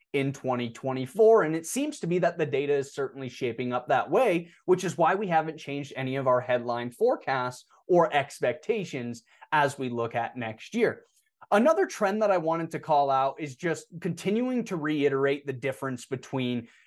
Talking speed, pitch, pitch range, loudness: 180 wpm, 145 Hz, 130-180 Hz, -27 LUFS